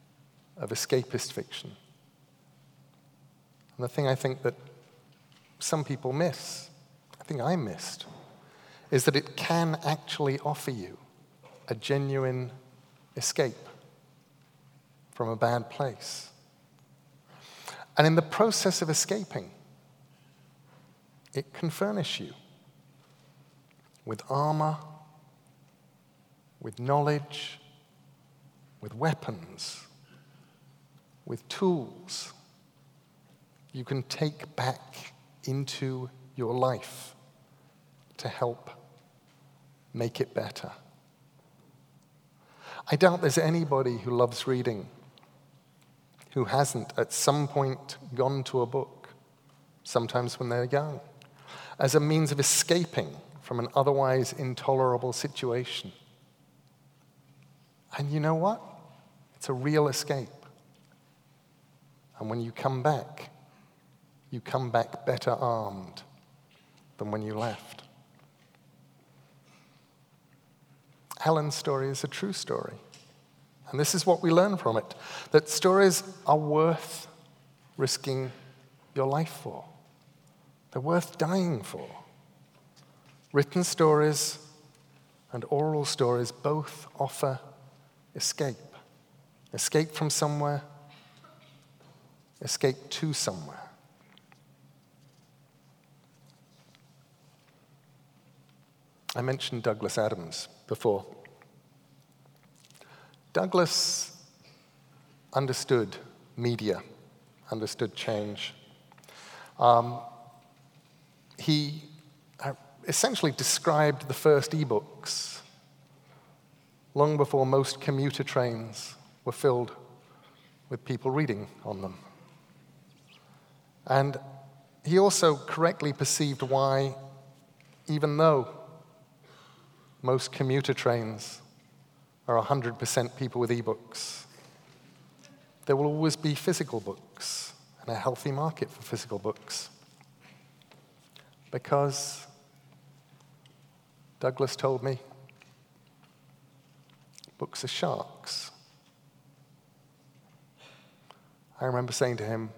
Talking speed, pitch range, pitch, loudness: 90 wpm, 130-150 Hz, 140 Hz, -29 LUFS